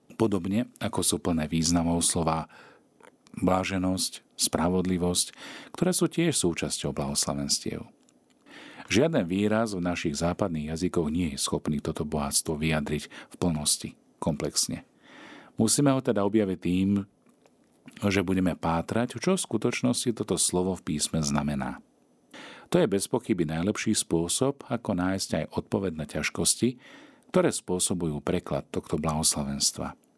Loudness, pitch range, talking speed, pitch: -27 LUFS, 80-105 Hz, 120 wpm, 90 Hz